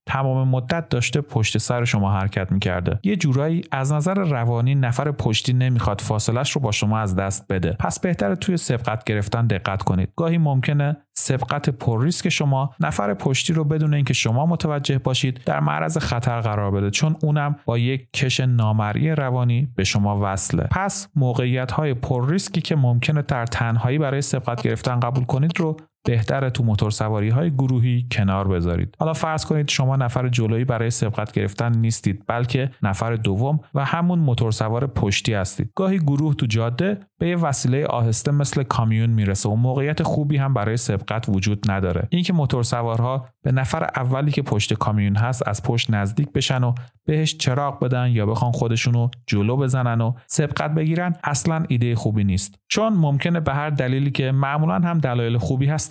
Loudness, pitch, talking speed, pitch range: -21 LUFS, 130 Hz, 170 wpm, 115-145 Hz